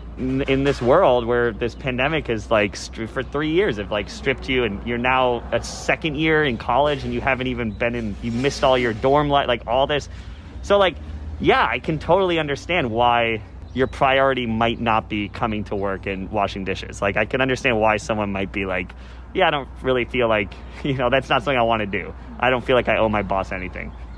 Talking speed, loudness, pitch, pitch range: 225 wpm, -21 LUFS, 120 Hz, 100-130 Hz